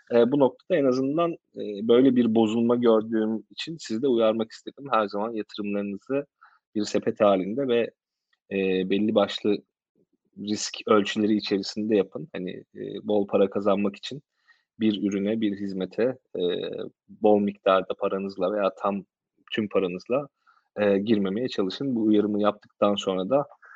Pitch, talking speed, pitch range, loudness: 105 Hz, 140 wpm, 100-115 Hz, -25 LUFS